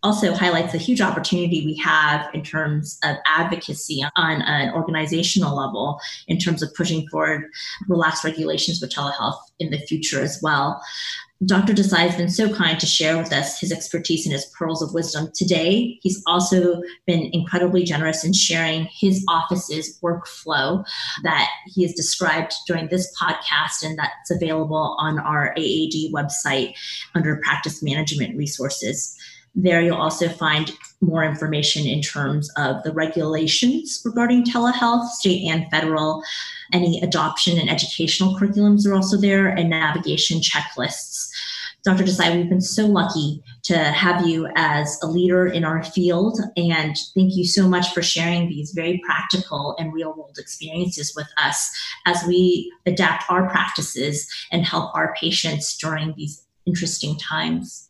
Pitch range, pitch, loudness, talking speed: 155-180 Hz, 165 Hz, -20 LUFS, 150 wpm